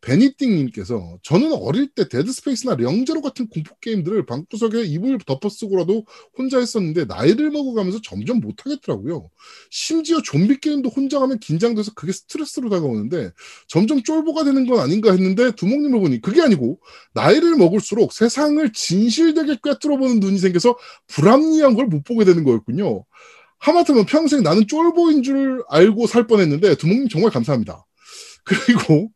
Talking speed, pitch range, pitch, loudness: 385 characters per minute, 195-280 Hz, 240 Hz, -18 LUFS